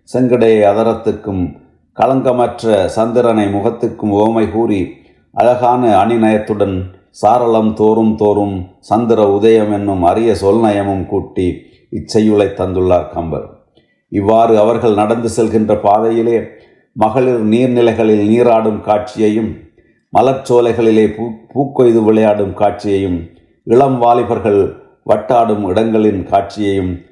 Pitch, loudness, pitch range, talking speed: 110 Hz, -13 LUFS, 100-115 Hz, 85 wpm